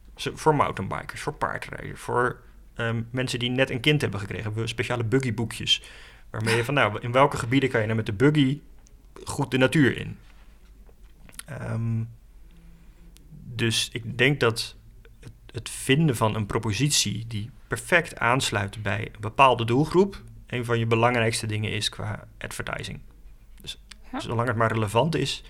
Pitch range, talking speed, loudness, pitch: 110-135 Hz, 150 wpm, -25 LUFS, 115 Hz